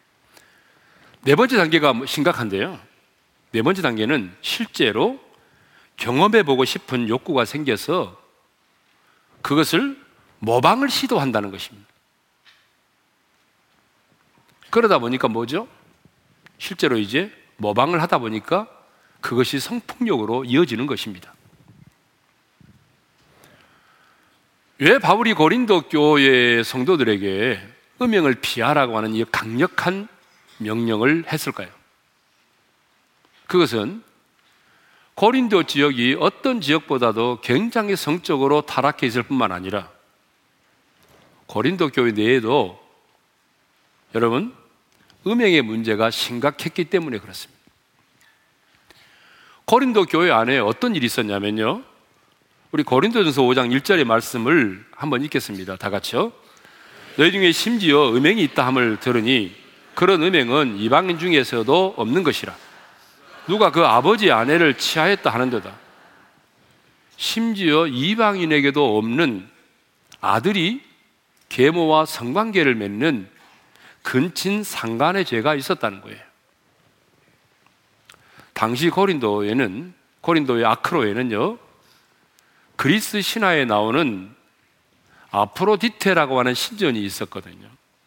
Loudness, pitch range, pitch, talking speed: -19 LUFS, 115-185 Hz, 140 Hz, 240 characters per minute